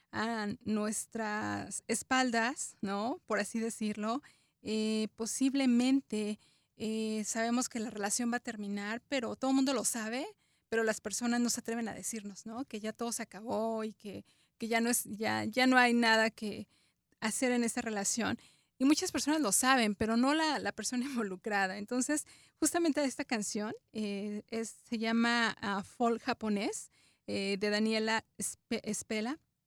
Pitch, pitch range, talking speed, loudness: 225 Hz, 215-245 Hz, 160 wpm, -33 LUFS